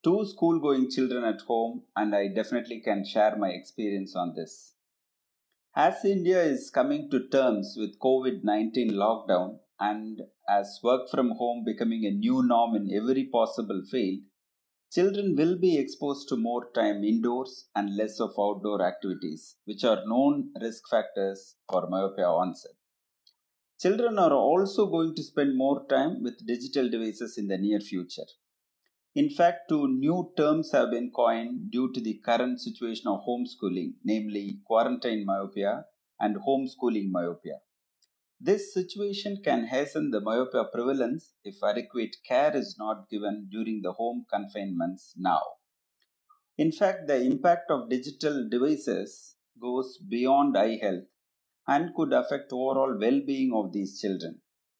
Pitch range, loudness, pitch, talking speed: 105-165 Hz, -28 LUFS, 120 Hz, 140 wpm